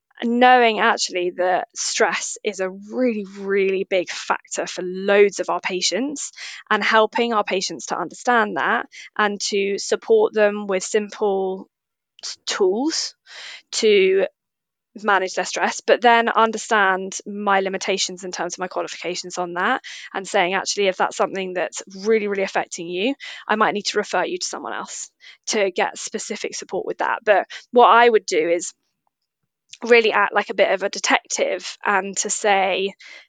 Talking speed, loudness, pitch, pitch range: 160 wpm, -20 LUFS, 200 Hz, 190-230 Hz